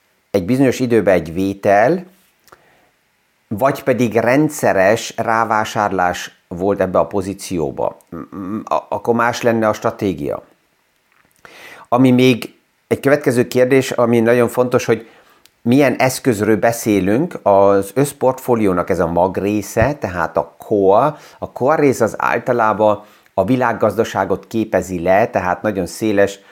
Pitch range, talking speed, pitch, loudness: 100-125 Hz, 115 wpm, 115 Hz, -16 LUFS